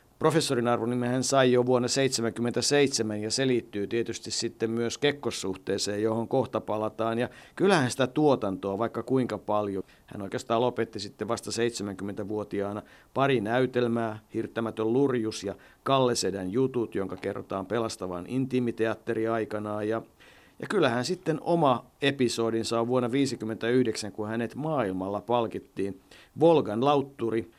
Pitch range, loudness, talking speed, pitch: 105-125 Hz, -28 LUFS, 125 wpm, 115 Hz